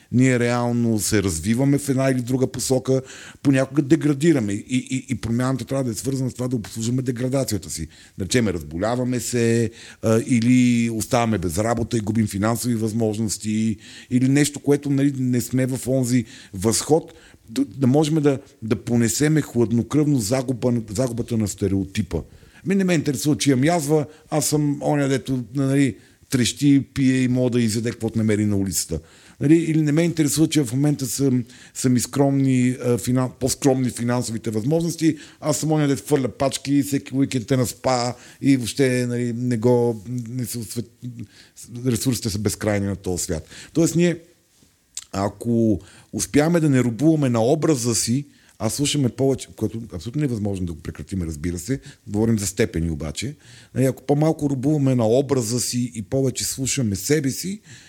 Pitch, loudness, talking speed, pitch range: 125 Hz, -21 LUFS, 160 wpm, 110-140 Hz